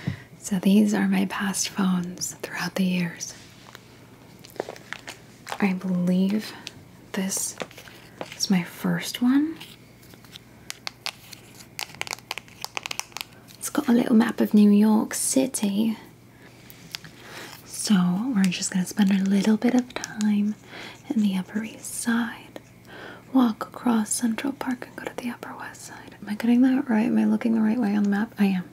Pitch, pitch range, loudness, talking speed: 210 Hz, 190-235 Hz, -24 LUFS, 140 wpm